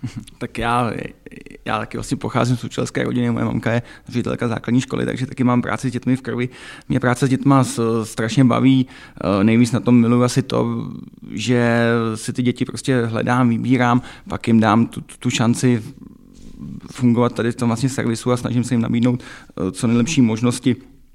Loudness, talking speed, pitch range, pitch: -19 LUFS, 175 wpm, 115-125 Hz, 120 Hz